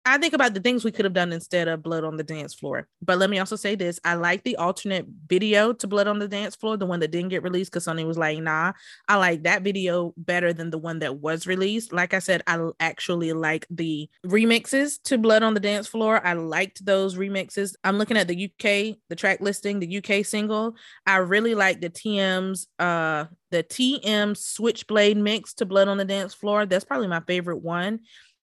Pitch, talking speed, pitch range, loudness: 190 Hz, 220 wpm, 175-210 Hz, -24 LUFS